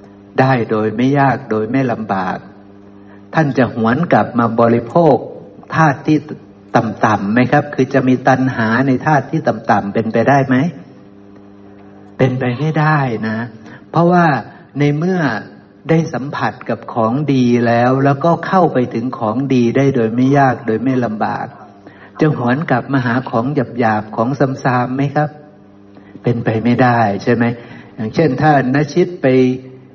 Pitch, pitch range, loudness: 125 Hz, 110-140 Hz, -15 LUFS